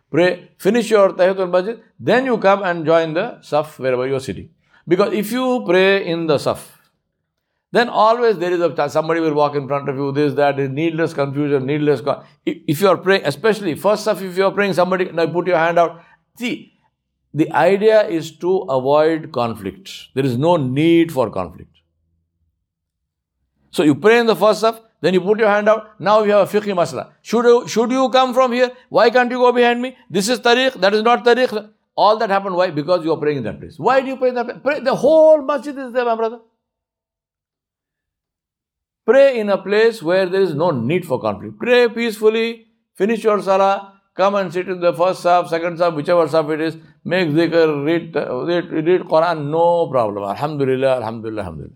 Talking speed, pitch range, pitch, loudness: 205 wpm, 150-220 Hz, 180 Hz, -17 LUFS